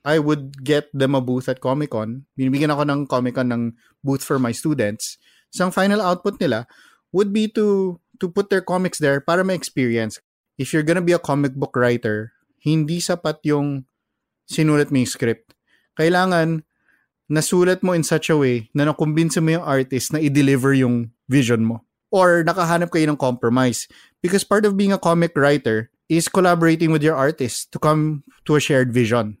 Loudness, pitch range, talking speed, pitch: -19 LUFS, 130-170 Hz, 180 wpm, 150 Hz